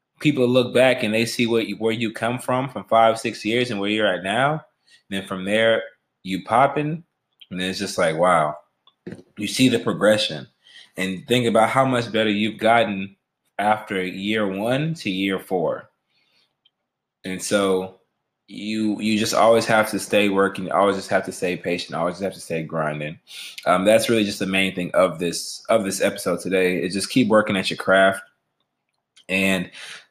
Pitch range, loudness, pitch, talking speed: 95-115 Hz, -21 LUFS, 105 Hz, 185 wpm